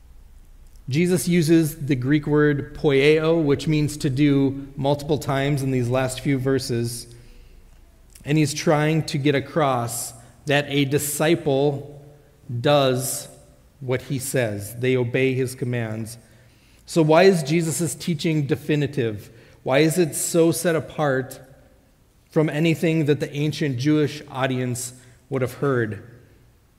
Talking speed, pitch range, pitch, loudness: 125 wpm, 120-150 Hz, 140 Hz, -22 LUFS